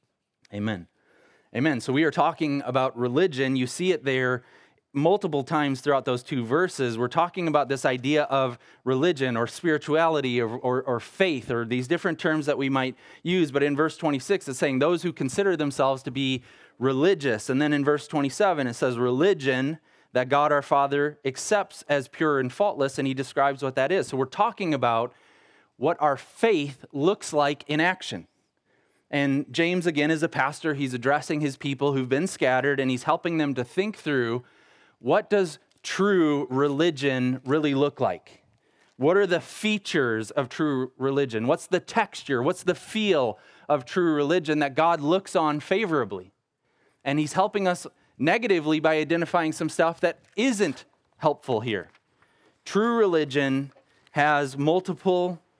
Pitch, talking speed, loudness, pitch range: 145 Hz, 165 wpm, -25 LUFS, 135-170 Hz